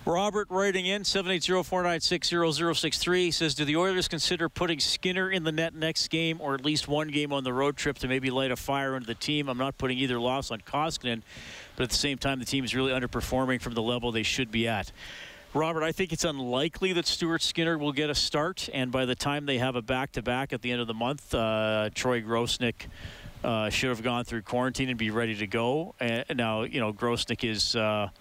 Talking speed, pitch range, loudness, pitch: 220 wpm, 120-160 Hz, -28 LUFS, 130 Hz